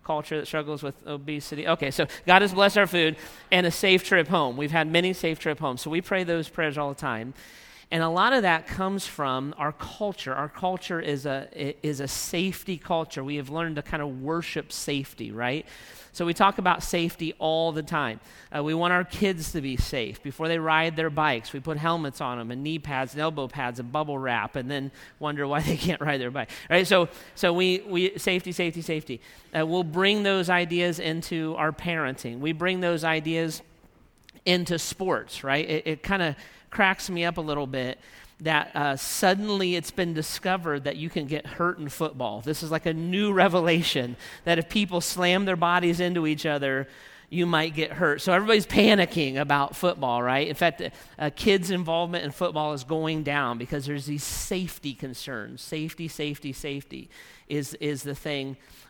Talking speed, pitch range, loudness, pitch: 200 wpm, 145-175 Hz, -26 LUFS, 160 Hz